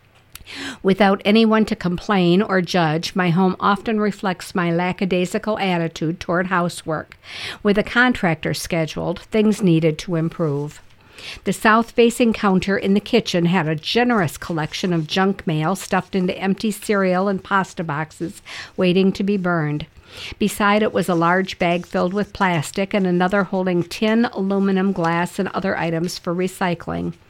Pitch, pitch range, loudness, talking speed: 185 Hz, 175-205 Hz, -19 LUFS, 150 wpm